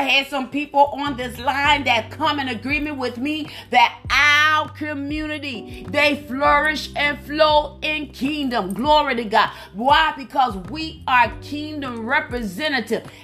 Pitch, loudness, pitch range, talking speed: 285 Hz, -19 LUFS, 250-300 Hz, 140 wpm